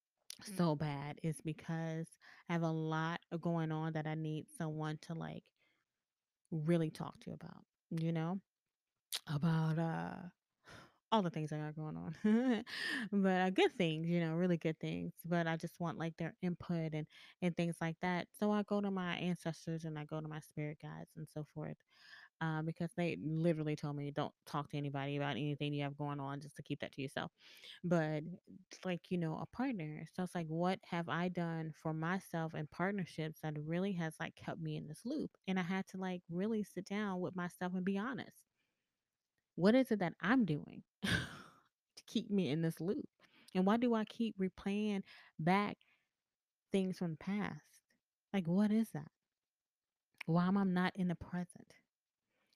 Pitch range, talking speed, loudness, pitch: 155-190 Hz, 185 wpm, -39 LUFS, 170 Hz